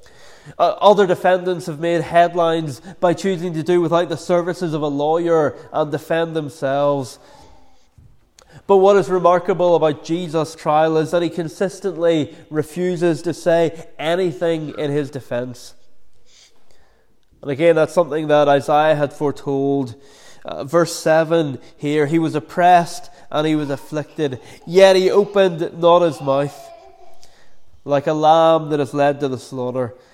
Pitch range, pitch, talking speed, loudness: 145-175 Hz, 160 Hz, 145 wpm, -18 LUFS